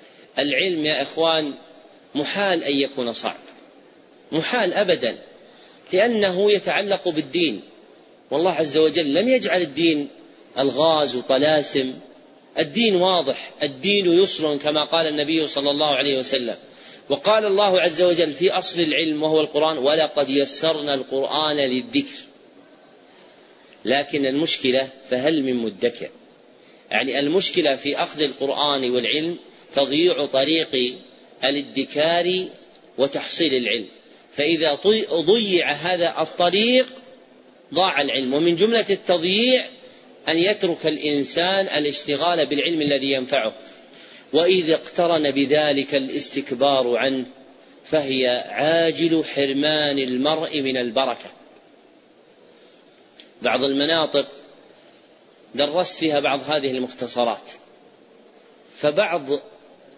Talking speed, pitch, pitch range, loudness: 95 wpm, 150 Hz, 140-175 Hz, -20 LUFS